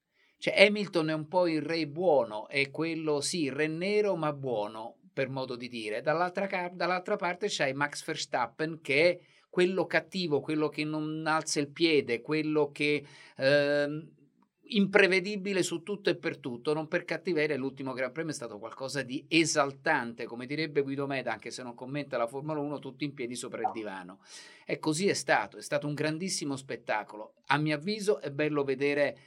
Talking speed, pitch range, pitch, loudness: 180 wpm, 140-170 Hz, 150 Hz, -30 LUFS